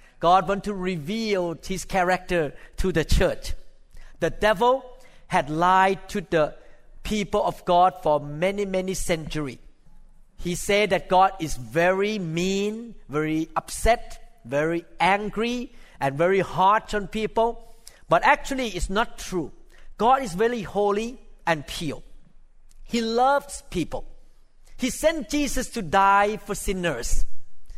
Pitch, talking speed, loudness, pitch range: 195 Hz, 125 wpm, -24 LUFS, 170-230 Hz